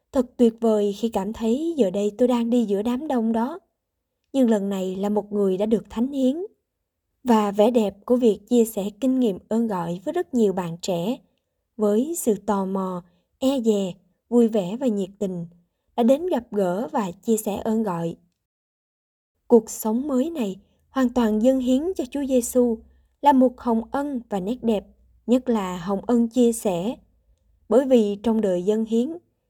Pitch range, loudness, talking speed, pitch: 205-250 Hz, -23 LUFS, 185 wpm, 225 Hz